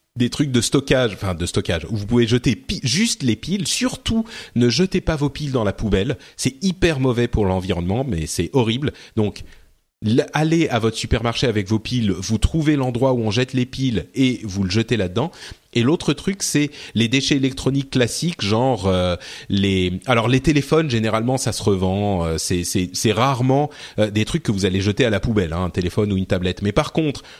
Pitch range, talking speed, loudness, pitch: 100-140 Hz, 210 wpm, -20 LUFS, 120 Hz